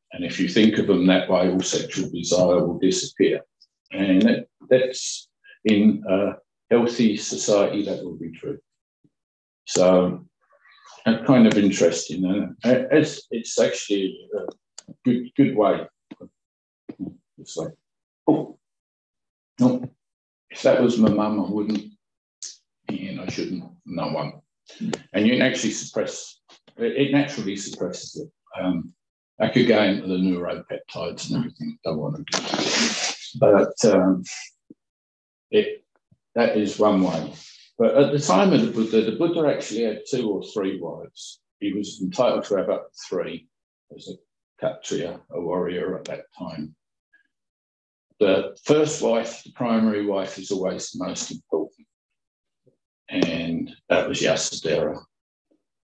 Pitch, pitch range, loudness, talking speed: 110 Hz, 95-140 Hz, -22 LUFS, 135 wpm